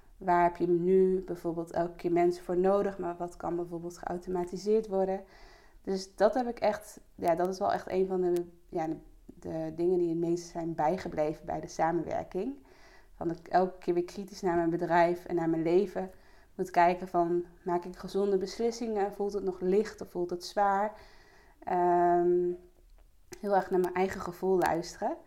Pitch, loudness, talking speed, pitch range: 180 Hz, -31 LUFS, 185 wpm, 175-190 Hz